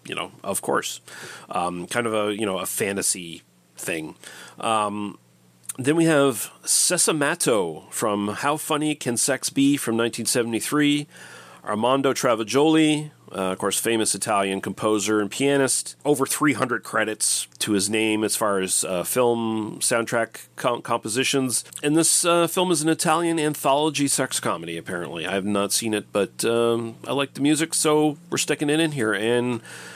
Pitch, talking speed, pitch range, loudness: 120 Hz, 160 wpm, 105-145 Hz, -22 LUFS